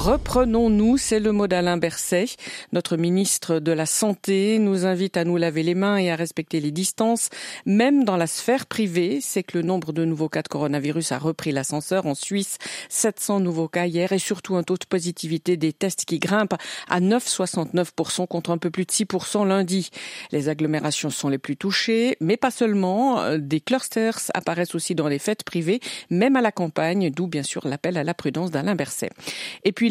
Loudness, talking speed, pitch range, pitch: -23 LUFS, 195 wpm, 165-210 Hz, 180 Hz